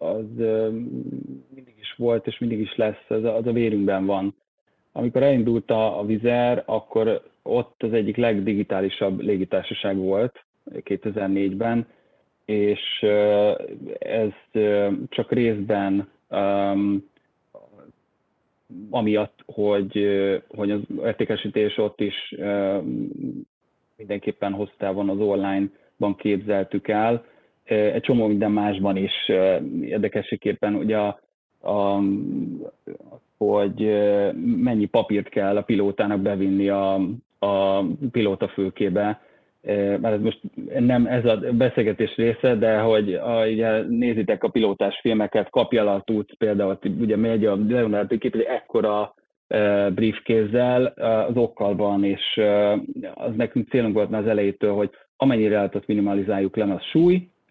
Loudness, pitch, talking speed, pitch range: -23 LUFS, 105 Hz, 125 wpm, 100-115 Hz